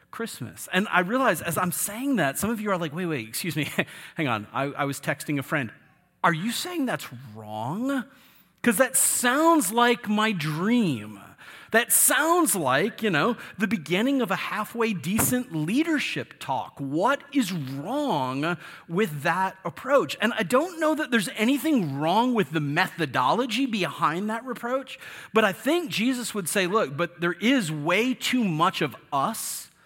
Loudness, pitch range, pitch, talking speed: -25 LUFS, 160-245 Hz, 205 Hz, 170 wpm